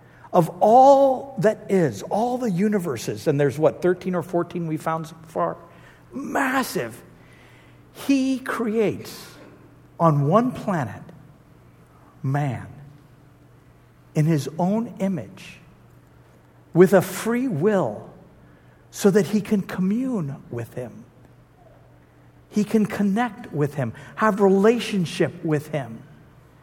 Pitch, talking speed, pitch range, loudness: 175 Hz, 110 wpm, 135-210 Hz, -22 LUFS